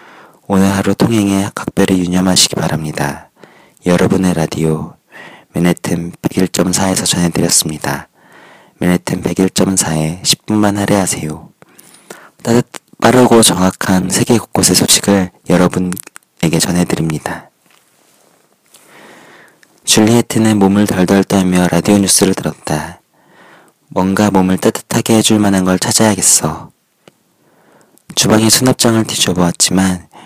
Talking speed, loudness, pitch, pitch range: 250 characters per minute, -12 LUFS, 95 Hz, 90-105 Hz